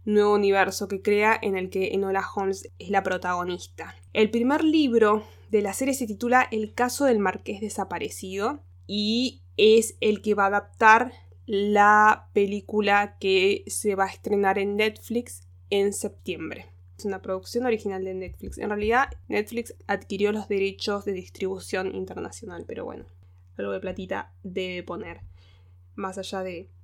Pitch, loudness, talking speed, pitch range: 200 Hz, -25 LUFS, 150 wpm, 180-215 Hz